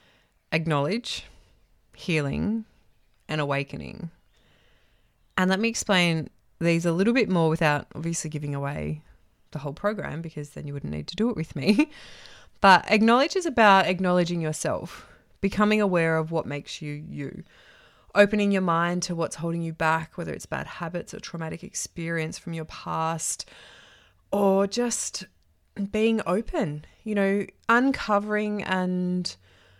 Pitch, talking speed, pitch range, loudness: 170 Hz, 140 wpm, 155-205 Hz, -25 LUFS